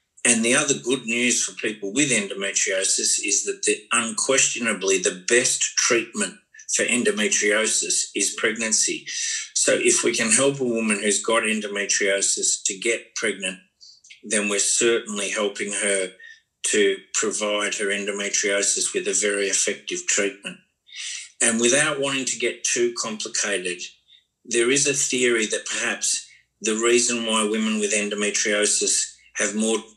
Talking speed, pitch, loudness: 135 wpm, 115 Hz, -21 LUFS